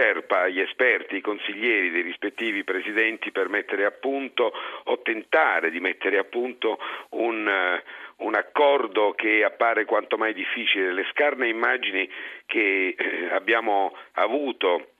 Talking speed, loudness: 125 wpm, -24 LUFS